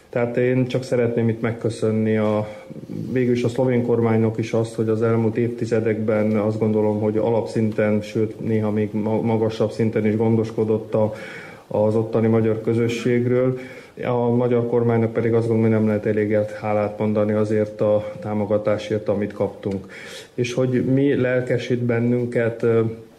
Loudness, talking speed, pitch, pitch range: -21 LUFS, 140 wpm, 115 Hz, 110-120 Hz